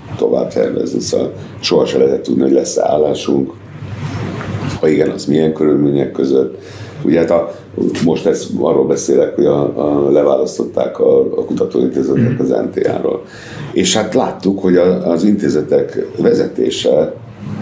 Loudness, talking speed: -14 LUFS, 135 wpm